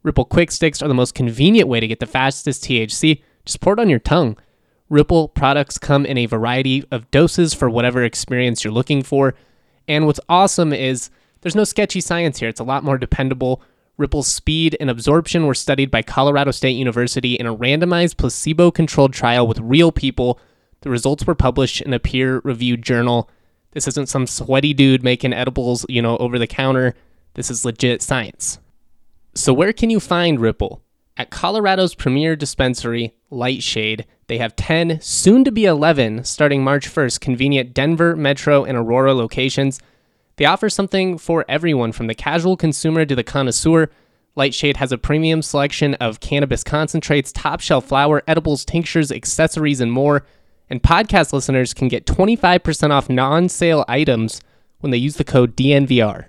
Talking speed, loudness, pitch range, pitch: 170 wpm, -17 LUFS, 125-155 Hz, 135 Hz